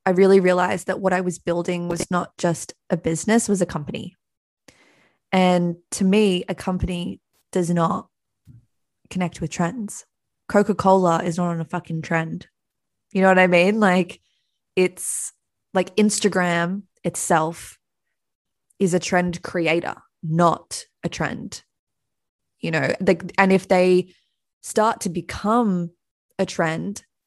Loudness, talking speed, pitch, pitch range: -21 LUFS, 135 wpm, 180 Hz, 170-190 Hz